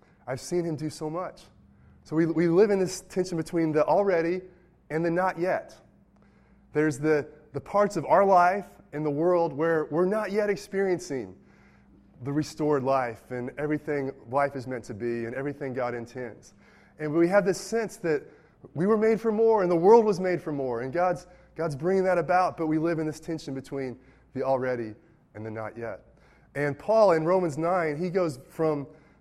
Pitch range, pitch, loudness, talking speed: 135-180 Hz, 160 Hz, -26 LUFS, 195 wpm